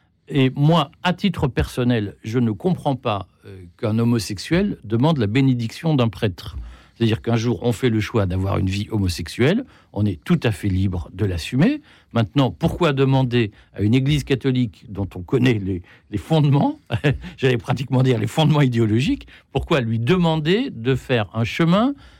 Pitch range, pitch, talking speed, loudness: 105-145 Hz, 120 Hz, 160 wpm, -20 LUFS